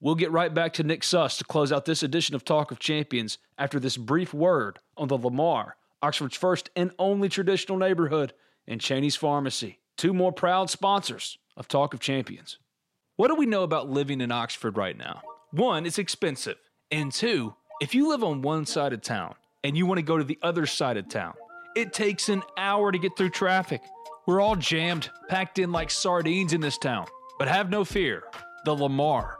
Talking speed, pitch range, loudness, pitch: 200 wpm, 145-190 Hz, -26 LUFS, 165 Hz